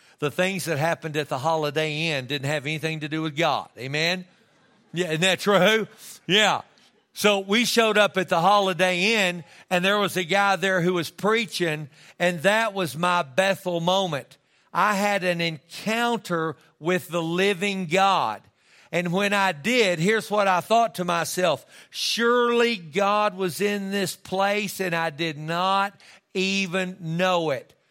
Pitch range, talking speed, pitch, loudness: 165-200 Hz, 160 wpm, 185 Hz, -23 LUFS